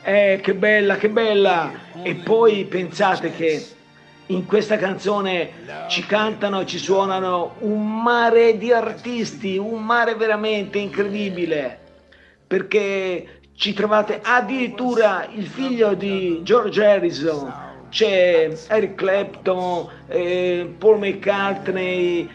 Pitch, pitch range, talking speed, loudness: 200 Hz, 180-215 Hz, 105 wpm, -20 LUFS